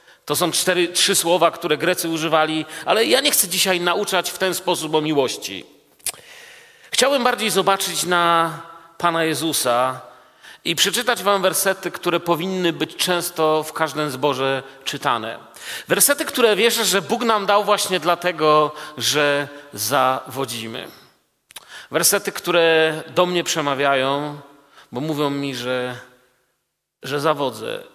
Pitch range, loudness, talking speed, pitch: 145-190 Hz, -19 LUFS, 125 wpm, 170 Hz